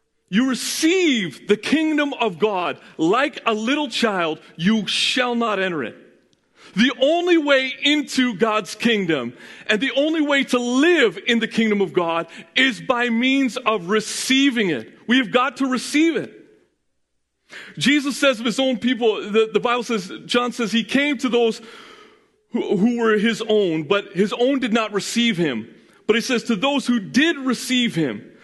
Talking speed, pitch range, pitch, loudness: 170 wpm, 215-270 Hz, 240 Hz, -20 LUFS